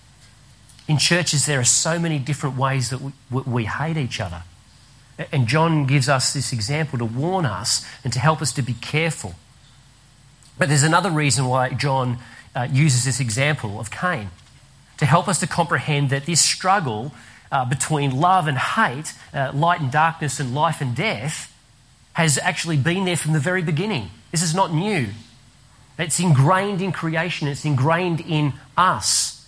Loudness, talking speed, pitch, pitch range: -20 LUFS, 170 wpm, 140 Hz, 125-160 Hz